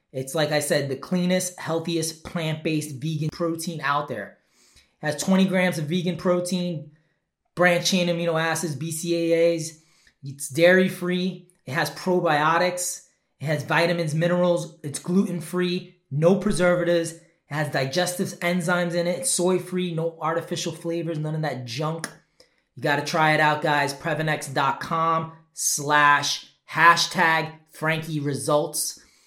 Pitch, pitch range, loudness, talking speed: 165 Hz, 155-180 Hz, -23 LUFS, 125 wpm